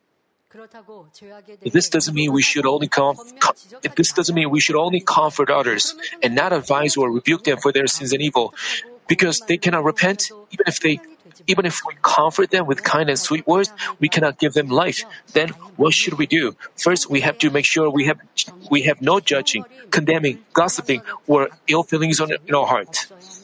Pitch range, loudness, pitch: 145-180 Hz, -18 LUFS, 155 Hz